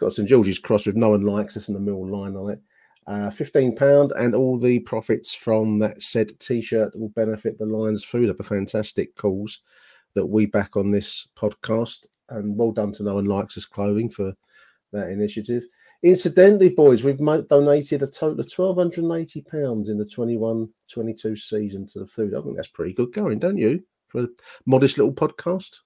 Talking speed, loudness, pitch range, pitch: 195 wpm, -22 LUFS, 105-130 Hz, 110 Hz